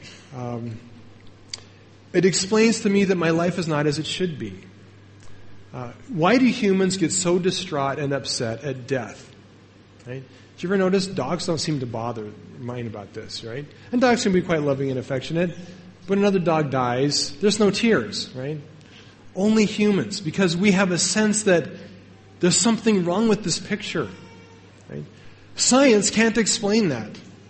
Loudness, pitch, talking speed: -21 LUFS, 150 Hz, 160 wpm